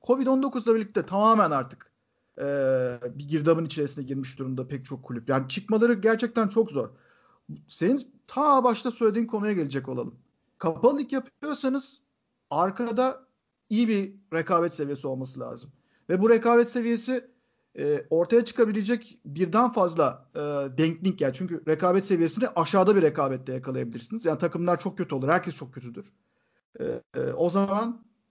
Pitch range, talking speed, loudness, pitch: 150-240 Hz, 140 wpm, -26 LUFS, 195 Hz